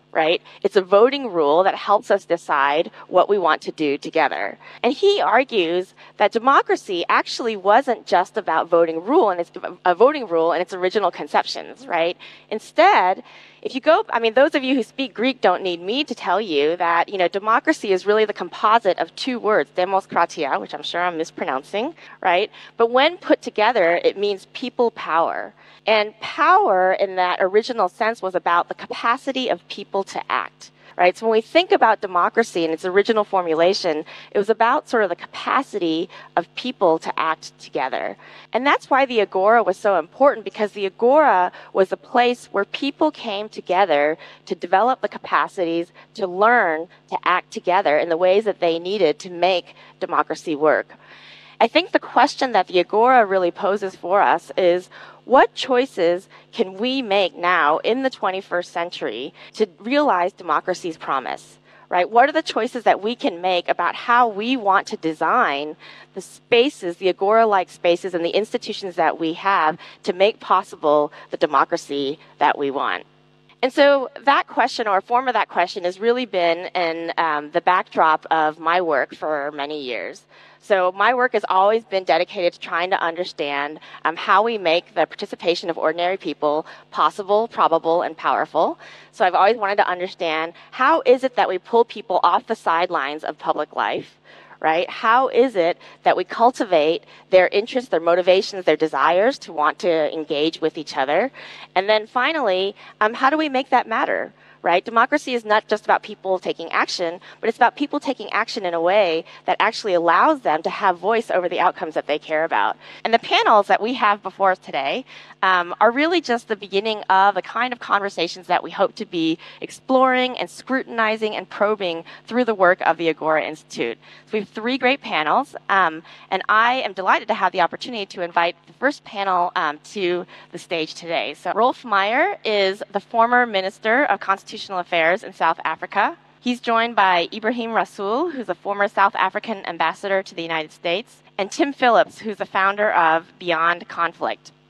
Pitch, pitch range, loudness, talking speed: 195 Hz, 175-230 Hz, -20 LUFS, 185 wpm